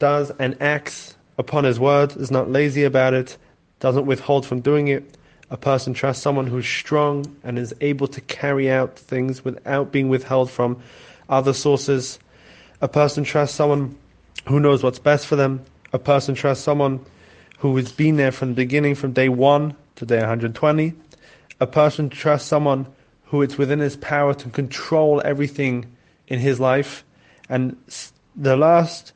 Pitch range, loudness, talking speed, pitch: 130-145 Hz, -20 LUFS, 170 wpm, 140 Hz